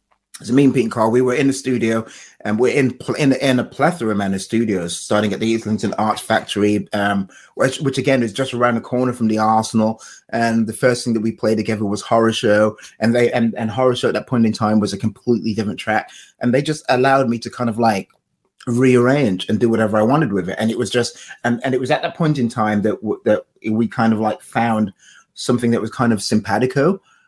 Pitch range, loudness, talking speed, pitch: 110-125 Hz, -18 LUFS, 240 wpm, 115 Hz